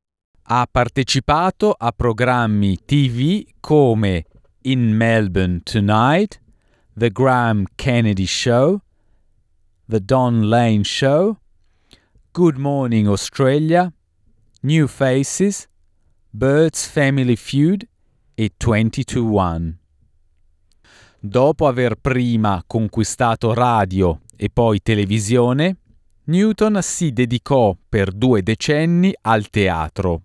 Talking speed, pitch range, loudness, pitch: 85 wpm, 100-135 Hz, -17 LUFS, 115 Hz